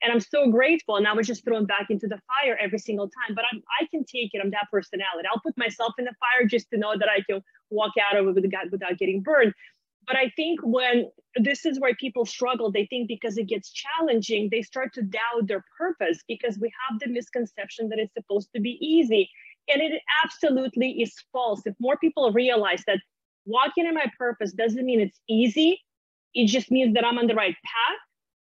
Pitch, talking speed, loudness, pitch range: 235 Hz, 215 wpm, -25 LUFS, 215-255 Hz